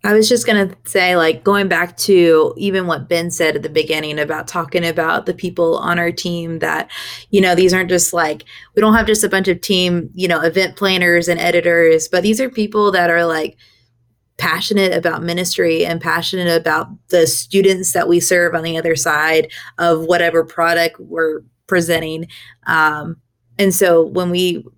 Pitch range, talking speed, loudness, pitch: 165-185 Hz, 190 wpm, -15 LUFS, 170 Hz